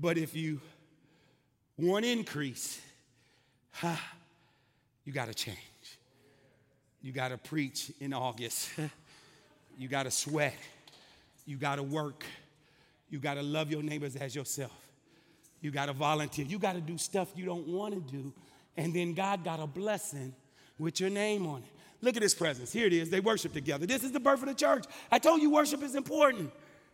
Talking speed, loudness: 180 wpm, -33 LUFS